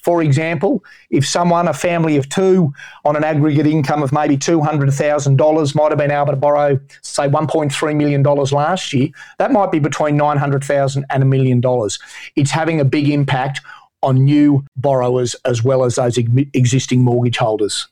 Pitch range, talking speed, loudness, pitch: 135-155 Hz, 165 wpm, -15 LUFS, 145 Hz